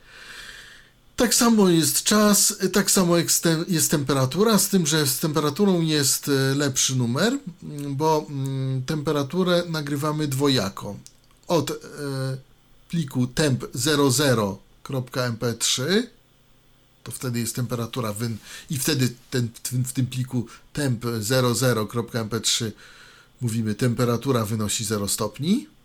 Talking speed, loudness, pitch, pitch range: 95 wpm, -22 LUFS, 135 Hz, 125-160 Hz